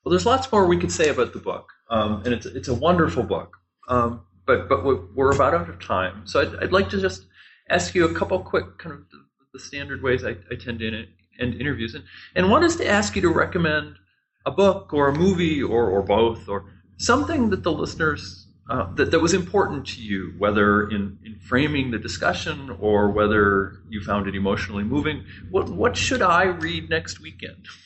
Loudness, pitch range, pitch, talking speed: -22 LUFS, 100-145 Hz, 115 Hz, 215 wpm